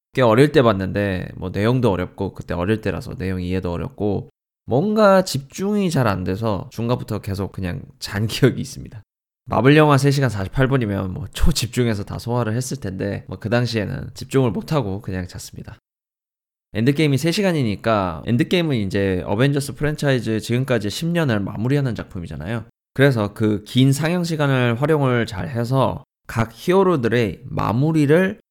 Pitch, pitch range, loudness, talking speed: 120 Hz, 100-140 Hz, -20 LUFS, 345 characters per minute